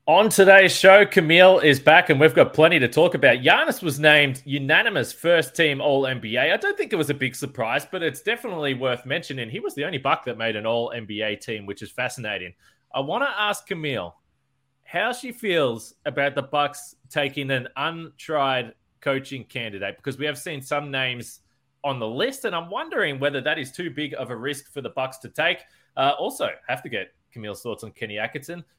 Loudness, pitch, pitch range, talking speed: -21 LUFS, 140 Hz, 125-155 Hz, 210 wpm